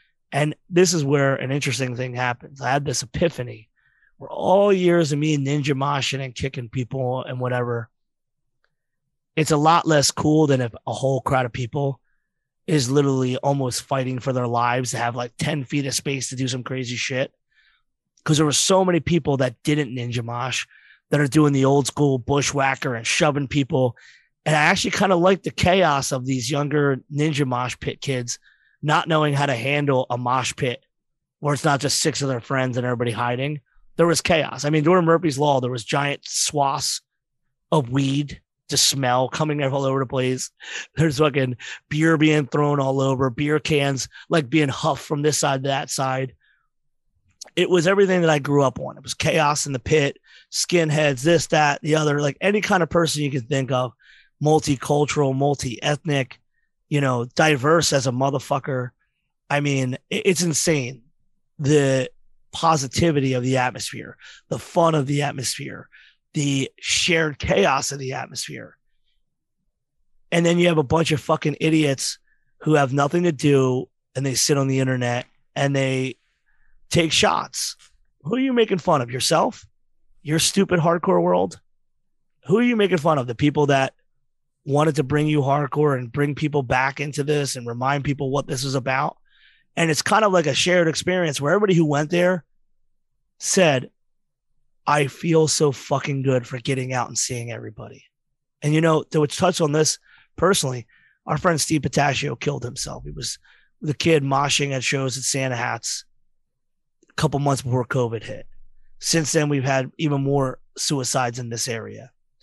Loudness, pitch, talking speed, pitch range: -21 LUFS, 140 Hz, 175 wpm, 130-155 Hz